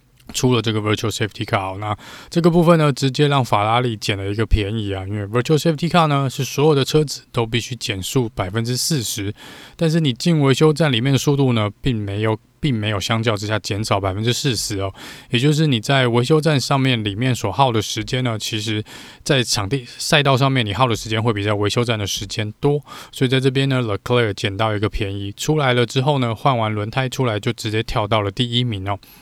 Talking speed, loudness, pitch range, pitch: 385 characters per minute, -19 LUFS, 105-135 Hz, 120 Hz